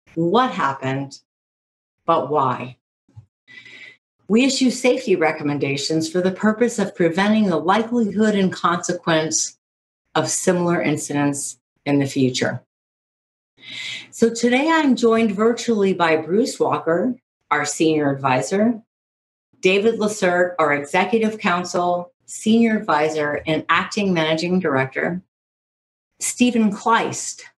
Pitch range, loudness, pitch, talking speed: 145-215 Hz, -19 LUFS, 175 Hz, 100 wpm